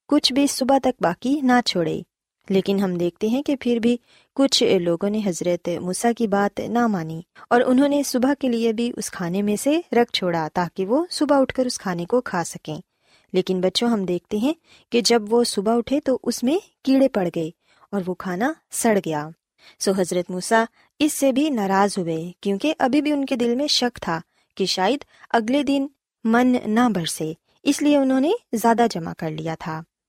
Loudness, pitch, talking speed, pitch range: -21 LUFS, 230 Hz, 200 wpm, 185-265 Hz